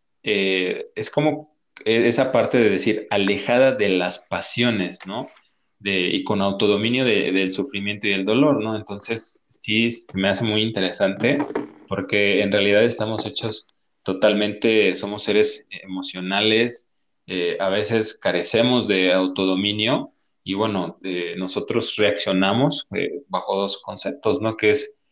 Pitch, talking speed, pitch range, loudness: 105 Hz, 135 wpm, 95-115 Hz, -21 LUFS